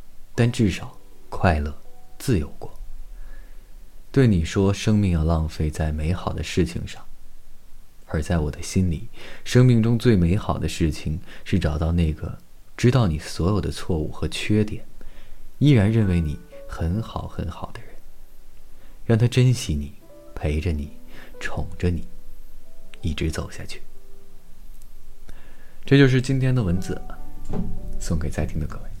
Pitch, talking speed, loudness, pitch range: 90 Hz, 200 characters per minute, -23 LUFS, 80-105 Hz